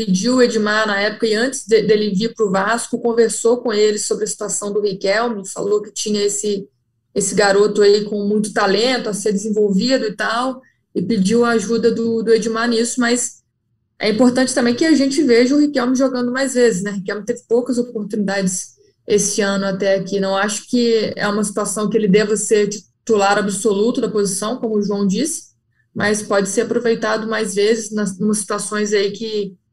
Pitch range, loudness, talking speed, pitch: 205-235 Hz, -17 LUFS, 195 wpm, 215 Hz